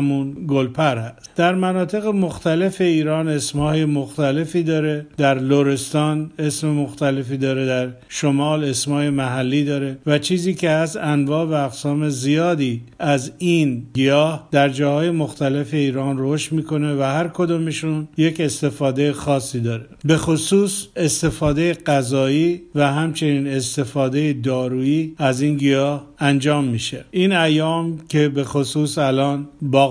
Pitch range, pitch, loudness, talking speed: 140-160 Hz, 145 Hz, -19 LUFS, 125 wpm